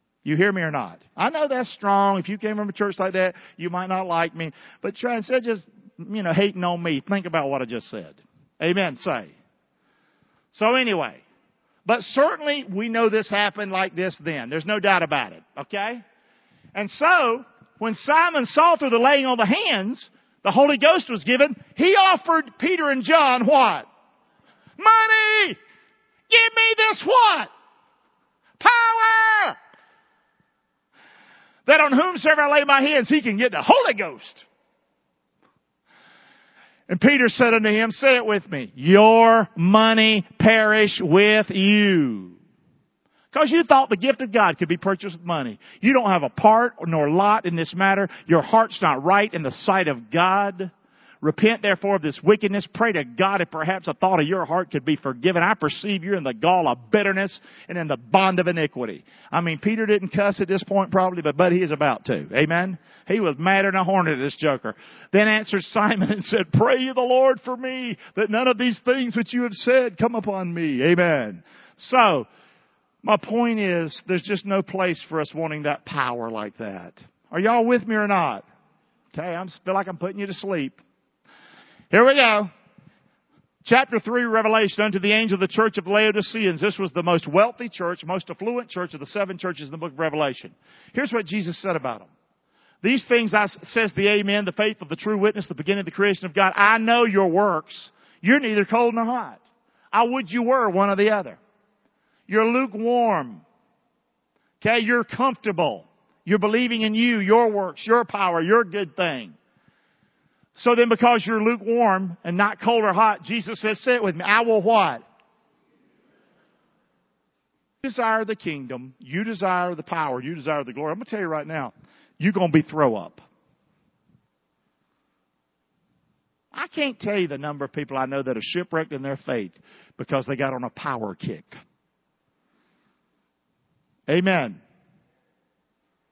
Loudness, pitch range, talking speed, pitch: -20 LUFS, 175-235 Hz, 180 wpm, 205 Hz